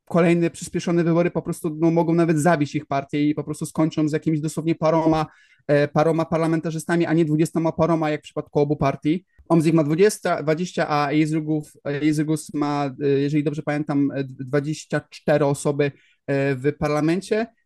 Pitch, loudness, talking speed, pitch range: 155 Hz, -22 LUFS, 150 wpm, 150-165 Hz